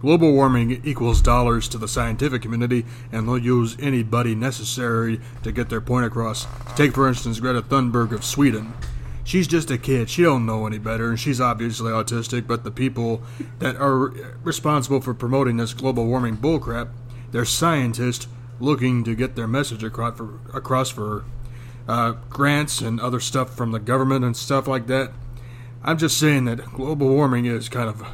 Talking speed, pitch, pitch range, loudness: 175 wpm, 120 Hz, 115-130 Hz, -22 LUFS